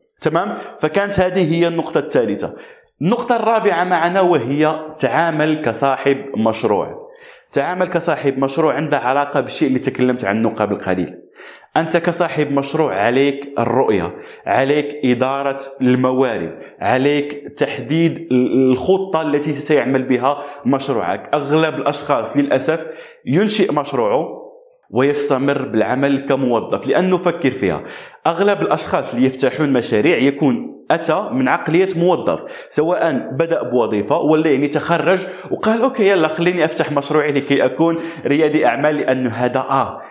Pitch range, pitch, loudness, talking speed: 135-170 Hz, 150 Hz, -17 LUFS, 120 wpm